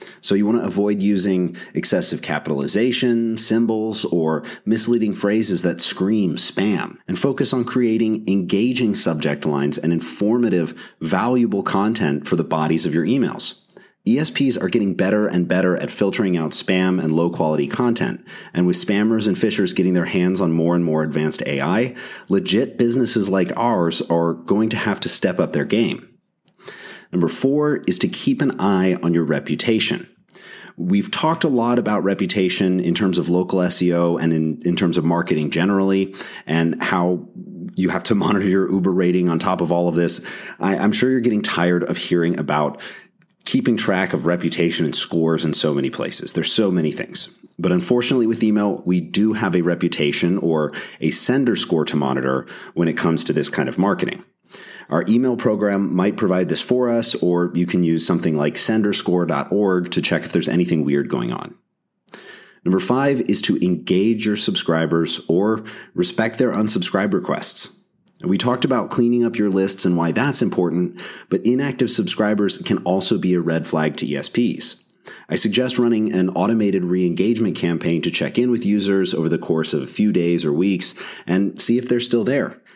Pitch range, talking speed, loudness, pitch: 85-110 Hz, 180 wpm, -19 LUFS, 95 Hz